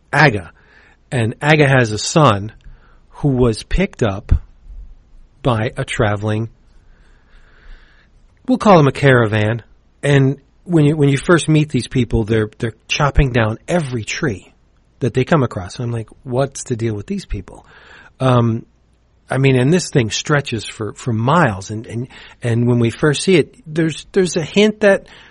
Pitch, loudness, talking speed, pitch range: 125 Hz, -16 LUFS, 165 wpm, 110-150 Hz